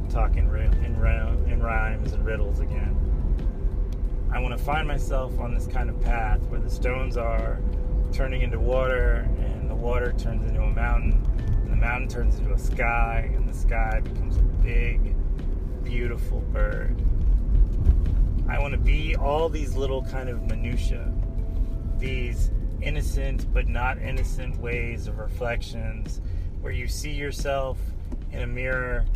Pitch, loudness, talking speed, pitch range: 85 Hz, -27 LUFS, 145 wpm, 75-110 Hz